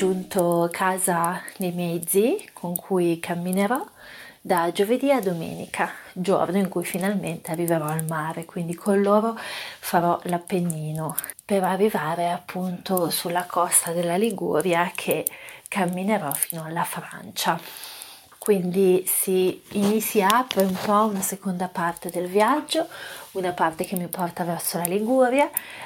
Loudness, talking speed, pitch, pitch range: -24 LUFS, 125 wpm, 185 Hz, 175-200 Hz